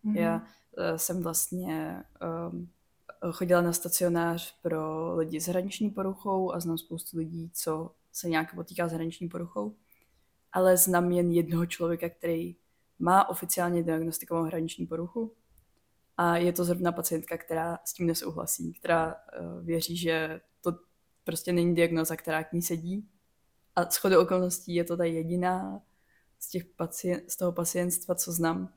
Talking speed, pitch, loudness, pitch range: 145 wpm, 170 Hz, -30 LUFS, 165-175 Hz